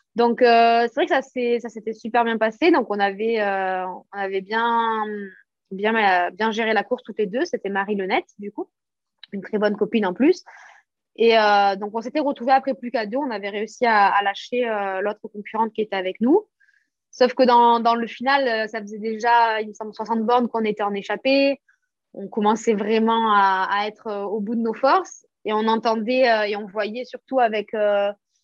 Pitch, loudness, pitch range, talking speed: 225 Hz, -21 LUFS, 205-240 Hz, 200 wpm